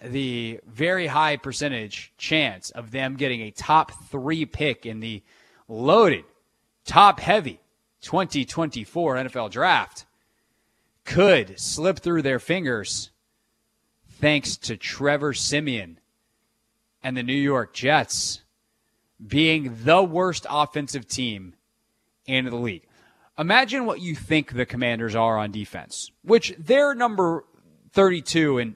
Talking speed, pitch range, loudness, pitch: 115 wpm, 115-160 Hz, -22 LUFS, 135 Hz